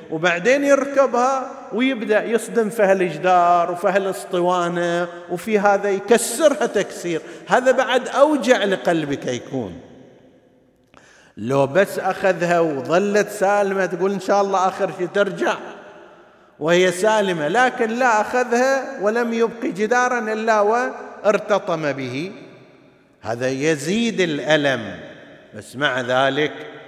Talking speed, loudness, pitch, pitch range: 105 wpm, -19 LUFS, 195 Hz, 175-230 Hz